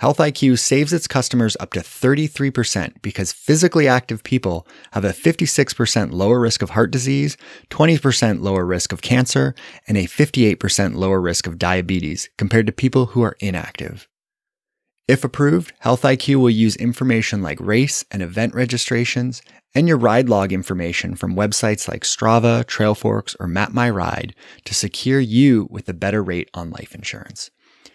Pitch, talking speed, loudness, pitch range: 115 Hz, 155 wpm, -18 LUFS, 100-130 Hz